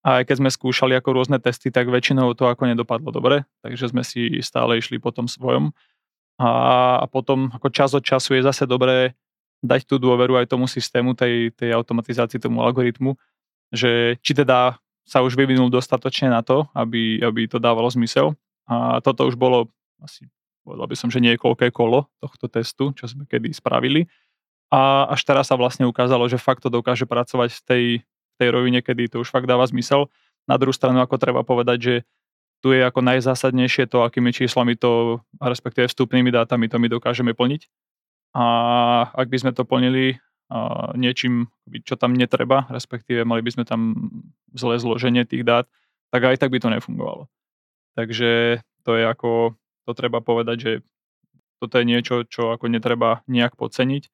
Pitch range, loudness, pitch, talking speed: 120-130 Hz, -20 LUFS, 125 Hz, 175 wpm